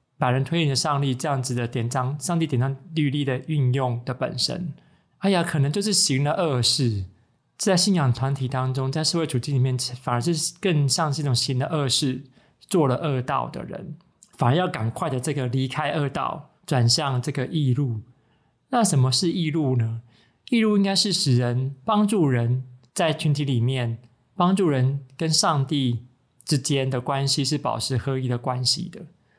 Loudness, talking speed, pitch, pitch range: -23 LUFS, 260 characters per minute, 135 Hz, 125-160 Hz